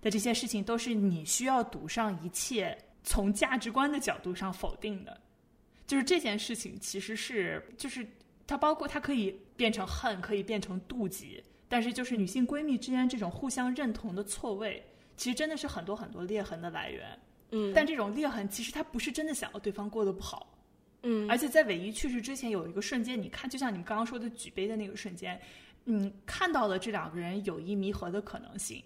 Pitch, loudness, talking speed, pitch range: 225 Hz, -33 LUFS, 320 characters per minute, 200-255 Hz